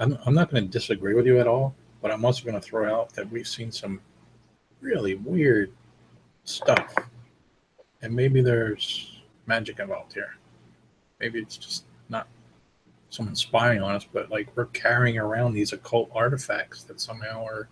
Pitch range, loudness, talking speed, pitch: 110-125 Hz, -26 LUFS, 165 wpm, 115 Hz